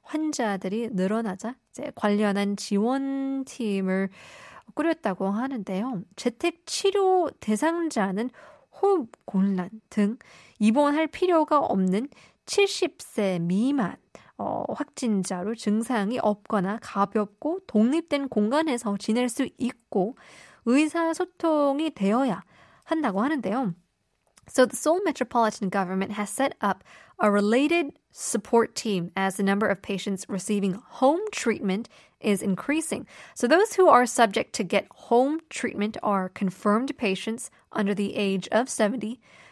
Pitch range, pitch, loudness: 200-285 Hz, 230 Hz, -26 LUFS